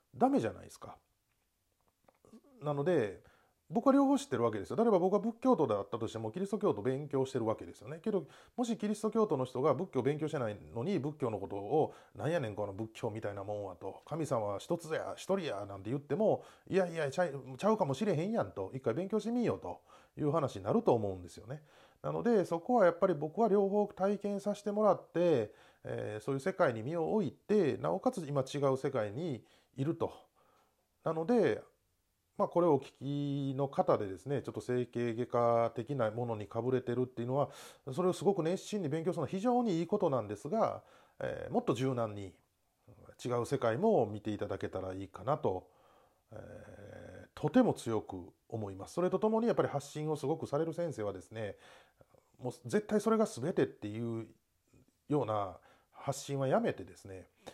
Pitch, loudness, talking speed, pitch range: 140 Hz, -34 LUFS, 385 characters per minute, 115-190 Hz